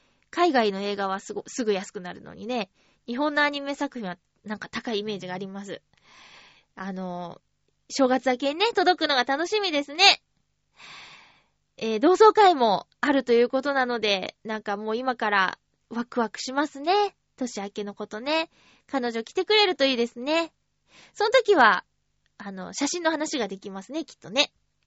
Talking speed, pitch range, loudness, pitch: 315 characters per minute, 205-295 Hz, -24 LUFS, 245 Hz